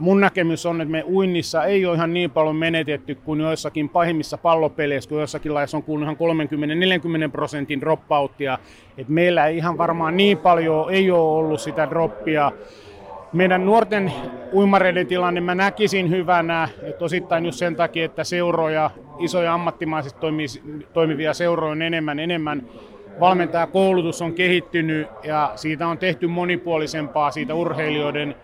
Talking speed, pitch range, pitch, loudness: 140 wpm, 150-175 Hz, 165 Hz, -21 LUFS